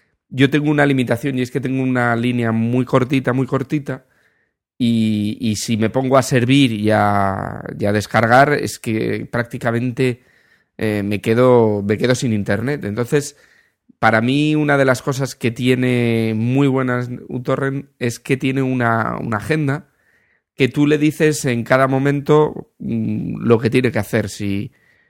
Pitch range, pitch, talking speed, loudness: 115-135 Hz, 125 Hz, 165 wpm, -17 LUFS